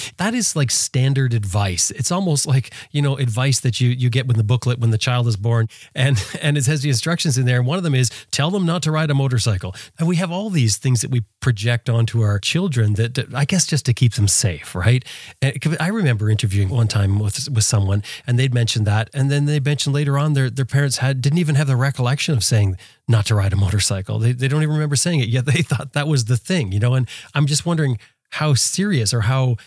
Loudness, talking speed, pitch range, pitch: -19 LUFS, 250 wpm, 115-145 Hz, 130 Hz